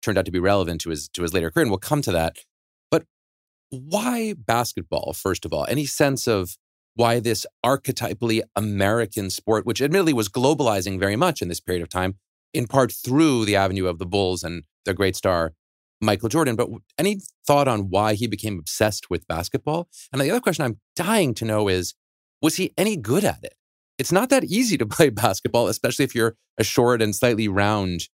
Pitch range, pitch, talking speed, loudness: 95-140 Hz, 115 Hz, 200 wpm, -22 LUFS